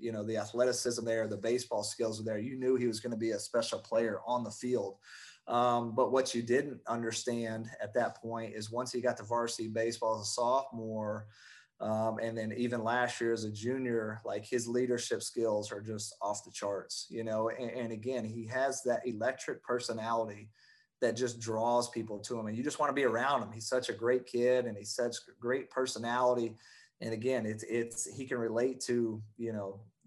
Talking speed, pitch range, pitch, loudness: 210 wpm, 110-125 Hz, 115 Hz, -34 LUFS